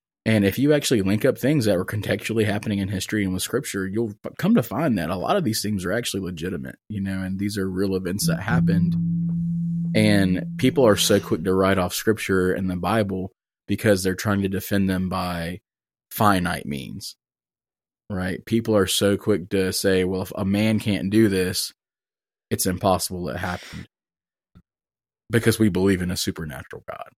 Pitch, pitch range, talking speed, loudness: 100 Hz, 95-110 Hz, 190 wpm, -22 LUFS